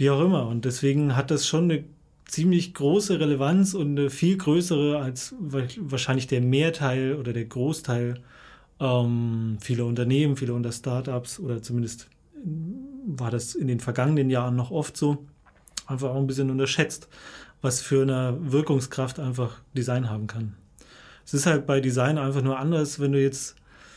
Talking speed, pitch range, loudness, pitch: 160 wpm, 125-150 Hz, -25 LUFS, 135 Hz